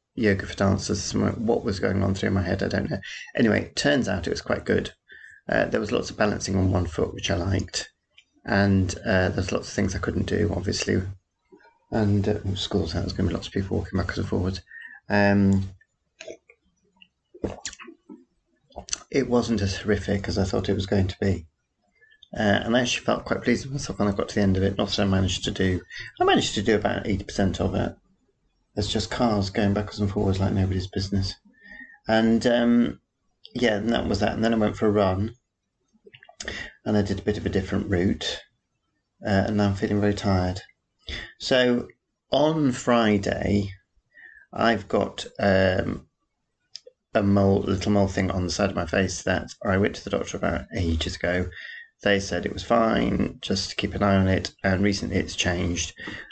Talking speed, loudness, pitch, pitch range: 195 wpm, -25 LUFS, 100 Hz, 95-105 Hz